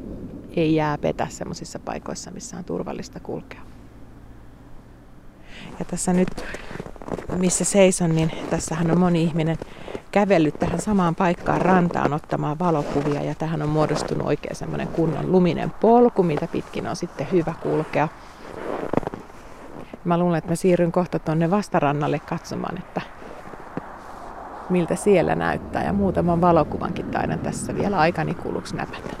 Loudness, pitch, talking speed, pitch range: -22 LUFS, 170 Hz, 130 wpm, 160-180 Hz